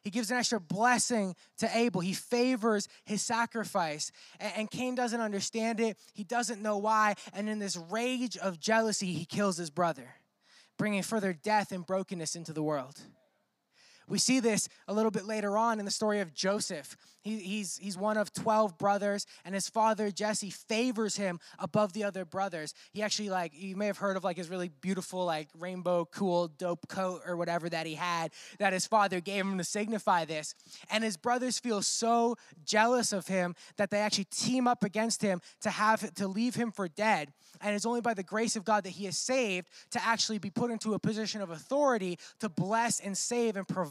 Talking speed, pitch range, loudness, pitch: 200 wpm, 185-220 Hz, -32 LUFS, 205 Hz